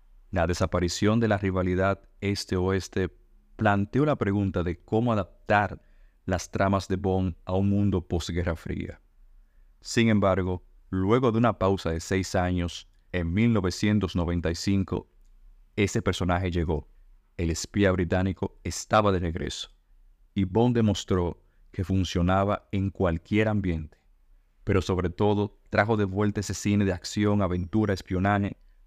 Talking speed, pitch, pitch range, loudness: 125 wpm, 95 Hz, 90-100 Hz, -27 LUFS